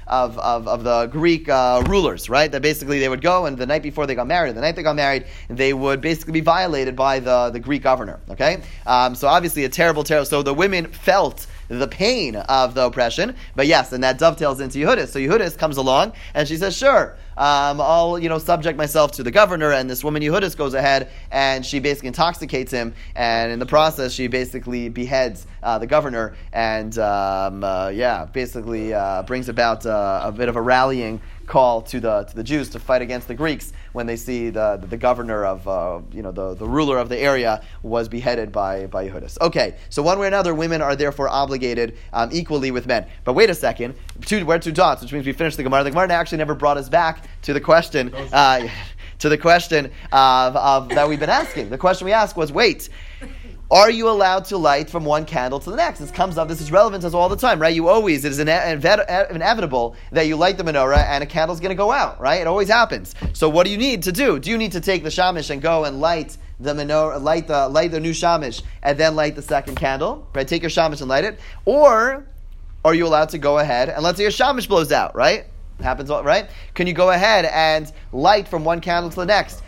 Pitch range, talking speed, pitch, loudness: 125-165 Hz, 235 wpm, 145 Hz, -19 LUFS